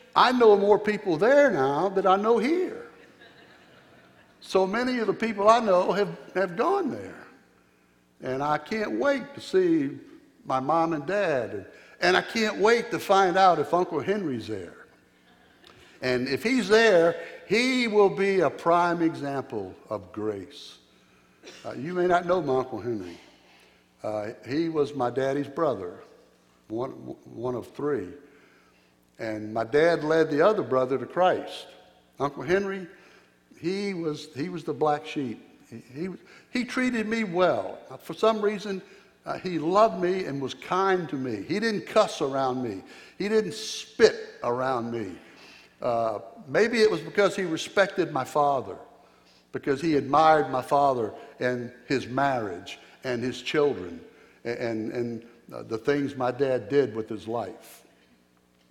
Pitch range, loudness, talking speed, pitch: 125-200 Hz, -26 LUFS, 155 wpm, 155 Hz